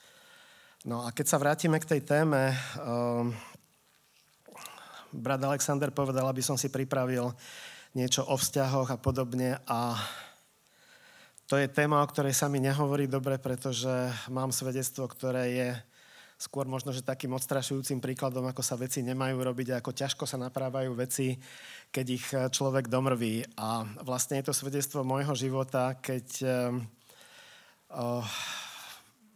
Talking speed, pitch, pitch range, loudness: 140 wpm, 130 Hz, 125-140 Hz, -31 LUFS